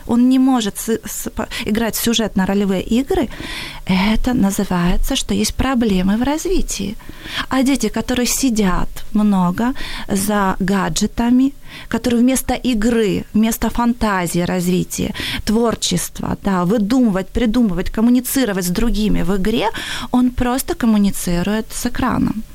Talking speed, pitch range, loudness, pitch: 115 wpm, 200-245 Hz, -17 LUFS, 225 Hz